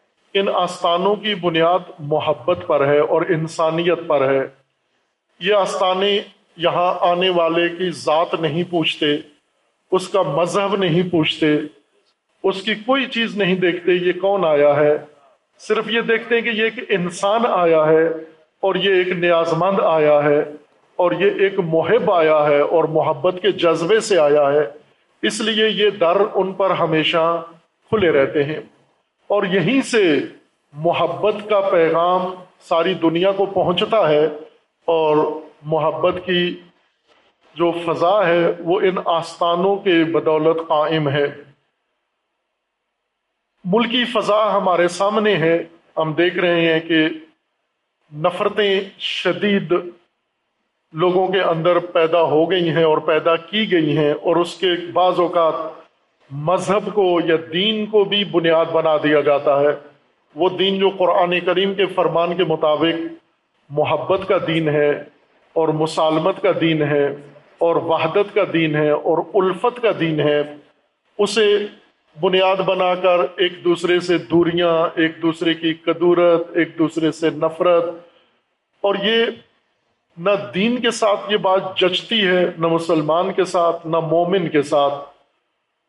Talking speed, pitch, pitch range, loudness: 140 wpm, 170 Hz, 160-190 Hz, -18 LUFS